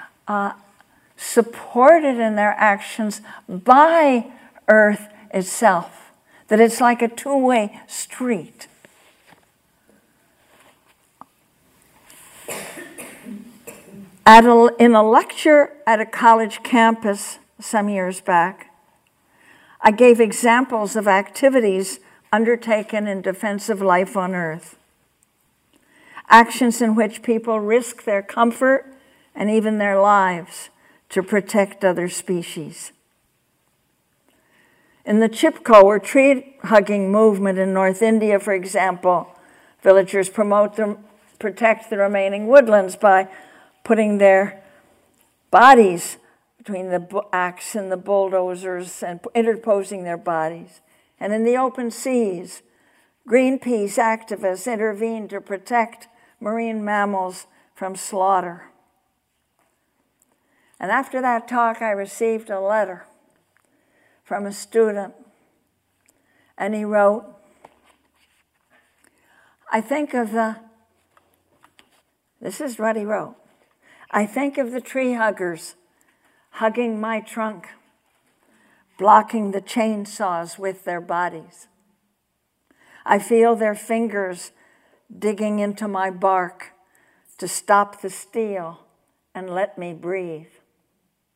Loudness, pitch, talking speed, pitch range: -18 LUFS, 210 Hz, 100 wpm, 195-230 Hz